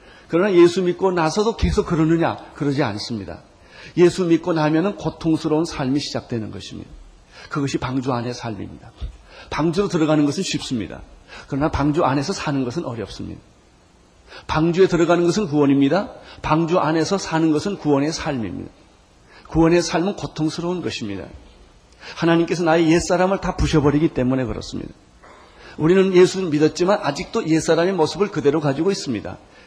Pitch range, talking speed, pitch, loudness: 135-175 Hz, 375 characters per minute, 160 Hz, -20 LUFS